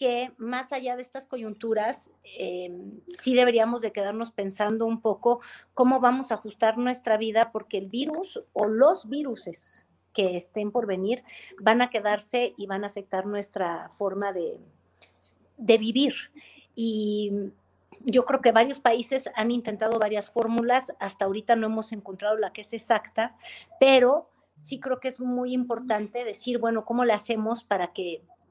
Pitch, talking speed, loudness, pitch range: 230 Hz, 160 wpm, -26 LUFS, 210-250 Hz